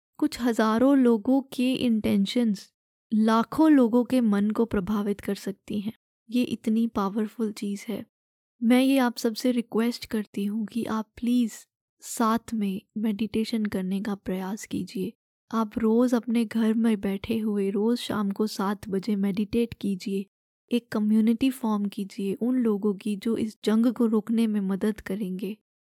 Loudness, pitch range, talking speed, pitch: -26 LUFS, 205-235 Hz, 150 wpm, 220 Hz